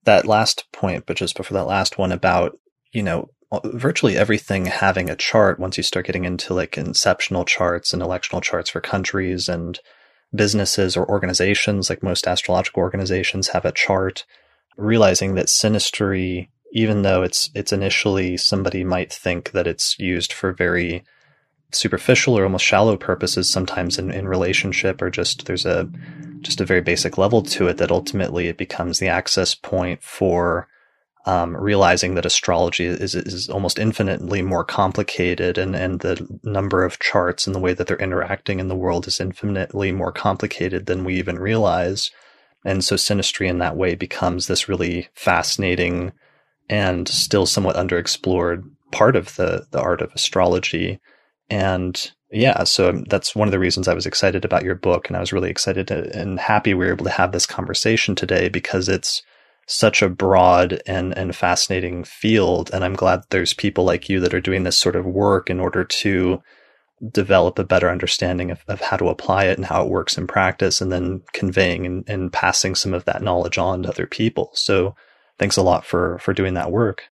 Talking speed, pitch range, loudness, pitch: 180 wpm, 90-100 Hz, -19 LUFS, 95 Hz